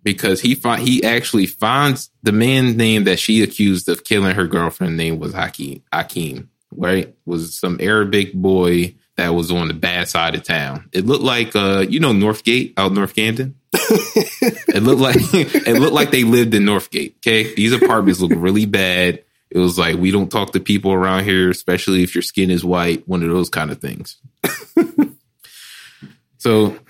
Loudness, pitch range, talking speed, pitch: -16 LUFS, 90-115 Hz, 185 wpm, 100 Hz